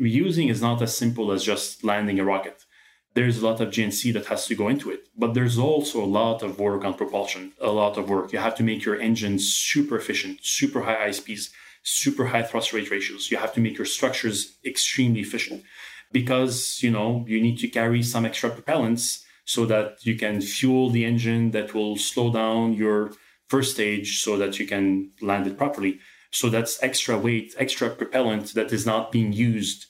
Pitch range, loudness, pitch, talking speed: 105-120 Hz, -24 LUFS, 115 Hz, 200 wpm